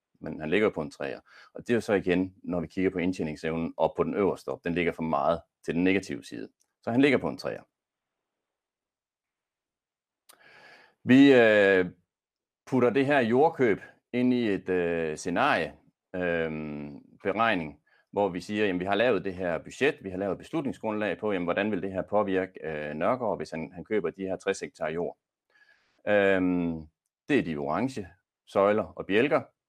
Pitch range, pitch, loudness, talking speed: 85-105 Hz, 95 Hz, -27 LUFS, 180 wpm